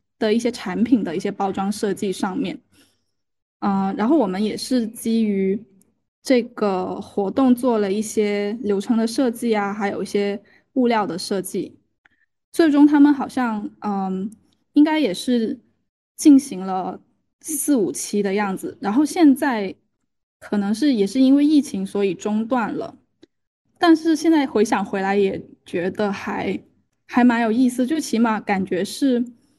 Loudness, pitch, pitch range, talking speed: -20 LUFS, 220 Hz, 200-265 Hz, 220 characters per minute